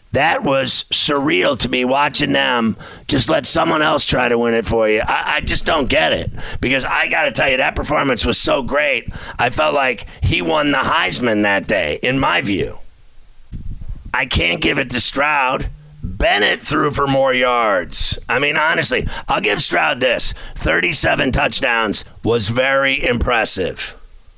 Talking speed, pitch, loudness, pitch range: 170 wpm, 125 Hz, -15 LUFS, 115-145 Hz